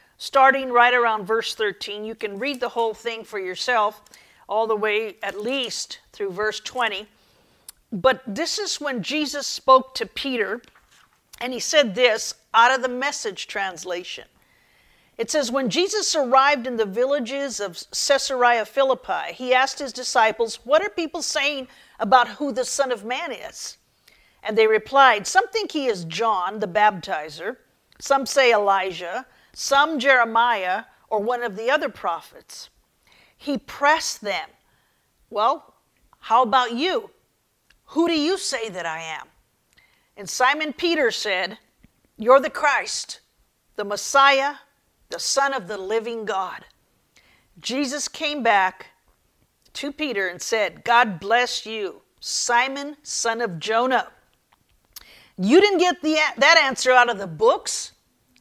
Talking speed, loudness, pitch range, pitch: 140 wpm, -21 LUFS, 220-285 Hz, 250 Hz